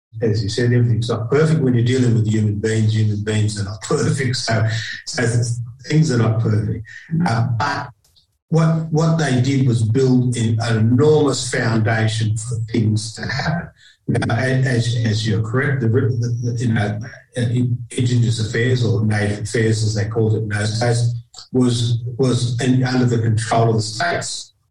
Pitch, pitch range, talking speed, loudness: 120 Hz, 110-125 Hz, 175 wpm, -18 LUFS